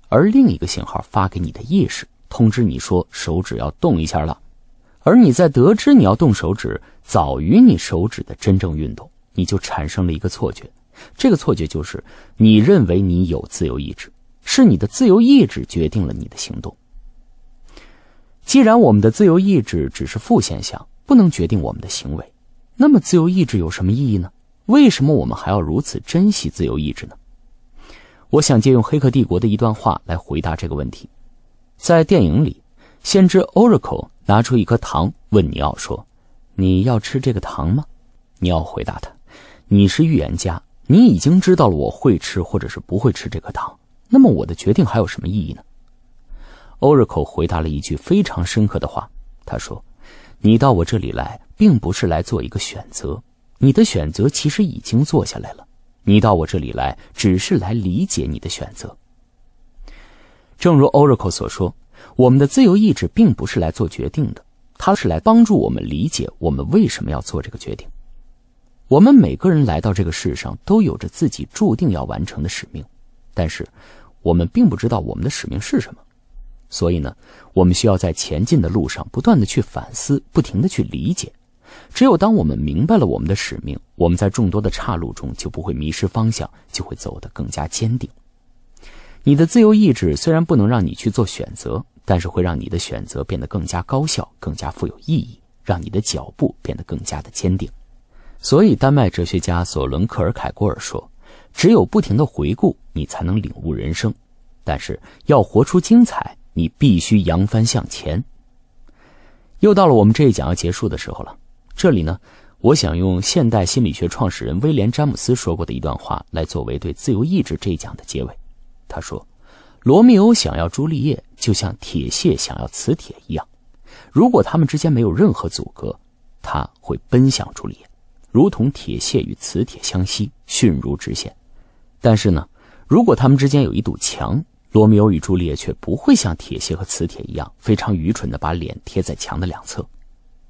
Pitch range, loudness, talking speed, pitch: 90-140 Hz, -16 LUFS, 285 characters per minute, 110 Hz